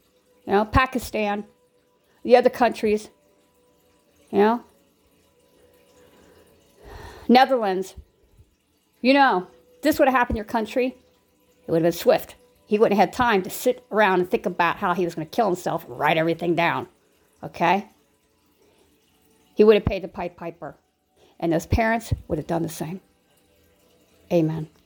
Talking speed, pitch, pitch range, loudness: 150 wpm, 185 Hz, 165-225 Hz, -22 LUFS